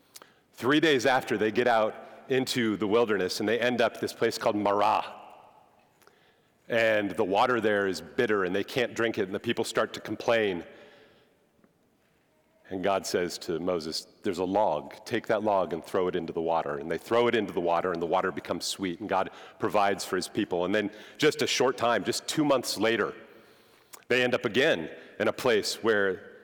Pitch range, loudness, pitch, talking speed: 90-120 Hz, -28 LUFS, 105 Hz, 200 wpm